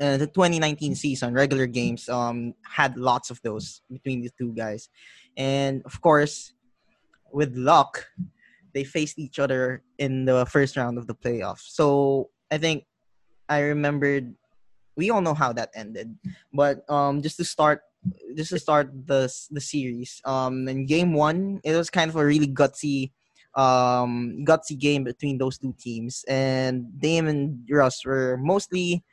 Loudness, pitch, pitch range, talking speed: -24 LUFS, 140 Hz, 130-155 Hz, 160 wpm